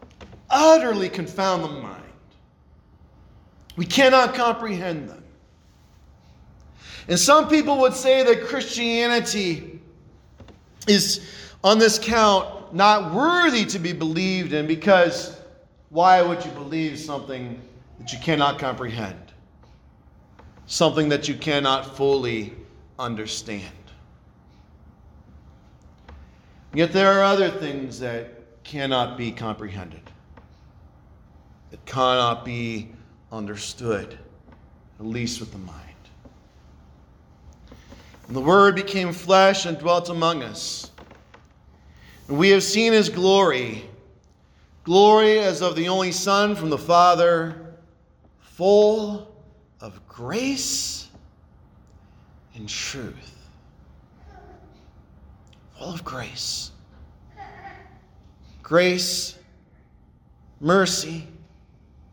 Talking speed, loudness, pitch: 90 wpm, -20 LUFS, 150 Hz